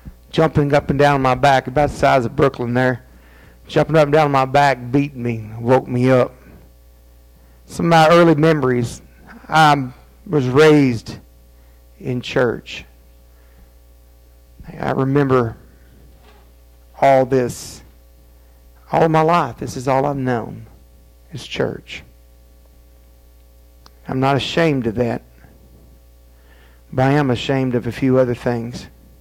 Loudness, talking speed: -17 LUFS, 125 wpm